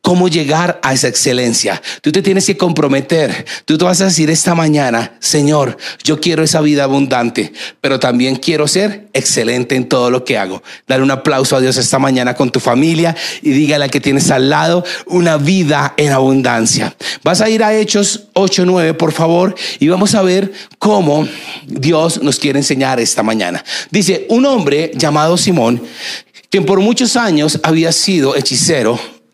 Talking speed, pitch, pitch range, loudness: 175 wpm, 155 Hz, 135-180 Hz, -12 LUFS